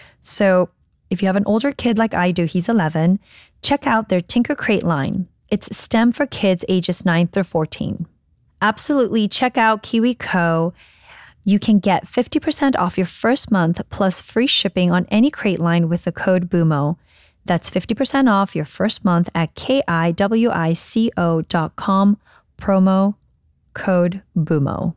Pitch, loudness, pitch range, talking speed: 195 Hz, -18 LUFS, 175-225 Hz, 145 wpm